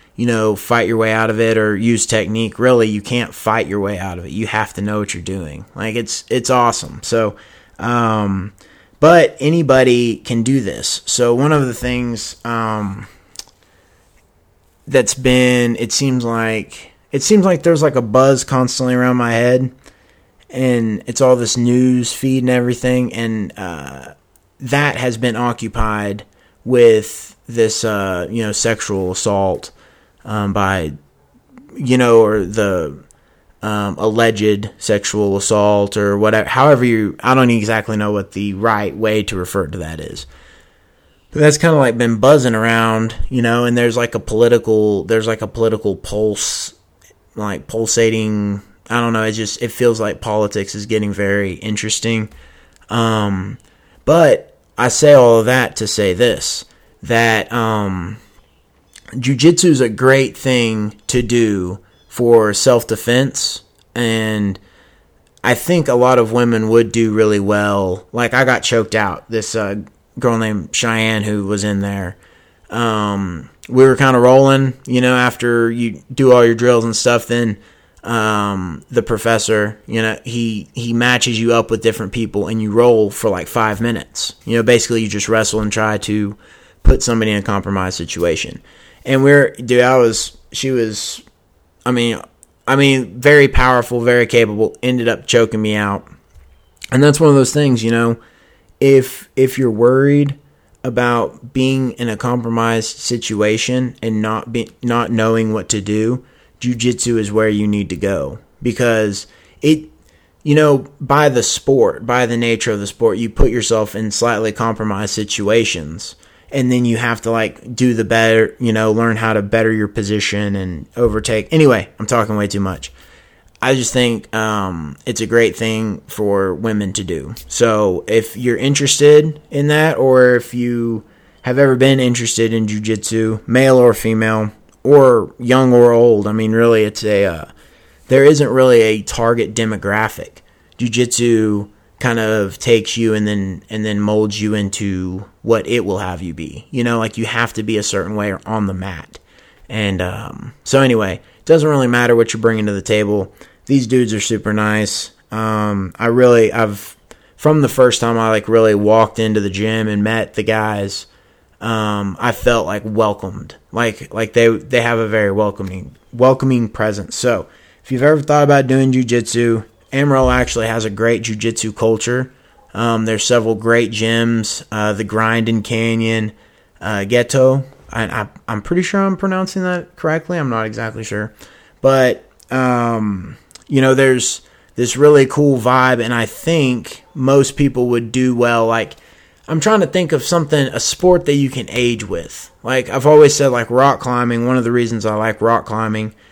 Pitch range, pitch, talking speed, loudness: 105-125 Hz, 115 Hz, 170 wpm, -15 LUFS